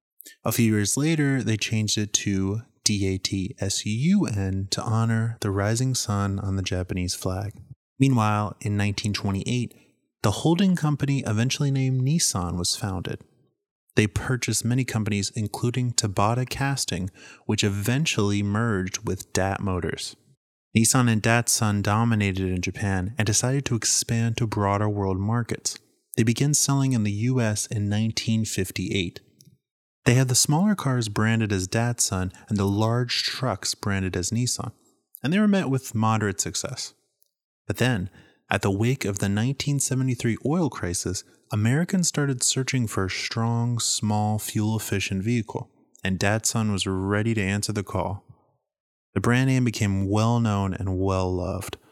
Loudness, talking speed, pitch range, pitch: -24 LUFS, 140 wpm, 100-125 Hz, 110 Hz